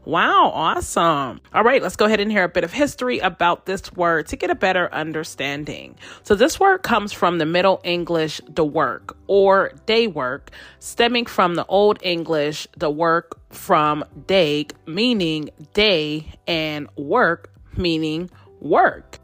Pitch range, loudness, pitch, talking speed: 155-200 Hz, -19 LUFS, 175 Hz, 155 wpm